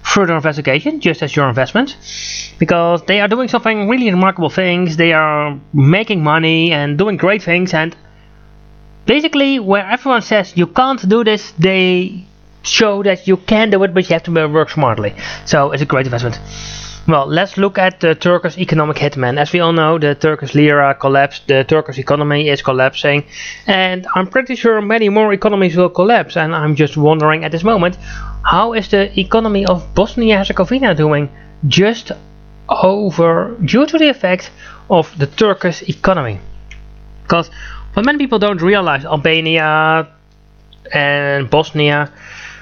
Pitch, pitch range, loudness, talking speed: 170 Hz, 145-200 Hz, -13 LUFS, 160 wpm